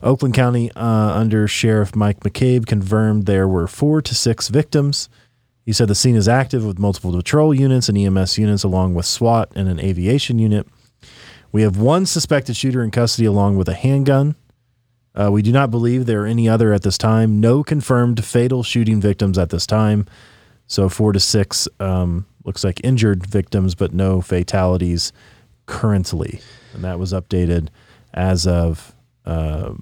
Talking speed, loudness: 170 wpm, -17 LUFS